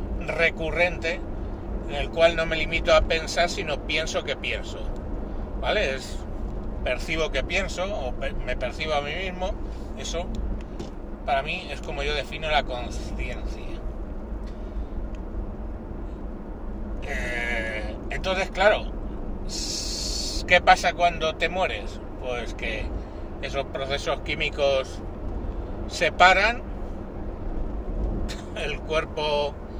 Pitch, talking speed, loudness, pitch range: 115 Hz, 95 wpm, -26 LUFS, 100-165 Hz